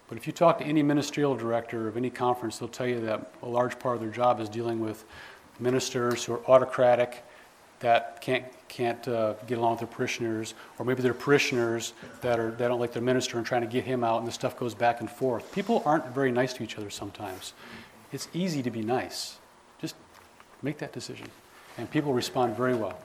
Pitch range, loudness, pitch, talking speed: 115-130 Hz, -28 LUFS, 120 Hz, 215 wpm